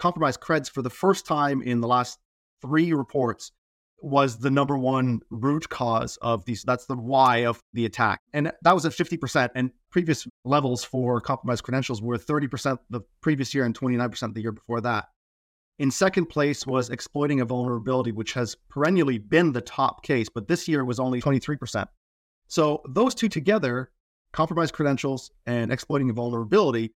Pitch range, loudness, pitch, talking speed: 120-150 Hz, -25 LUFS, 130 Hz, 175 wpm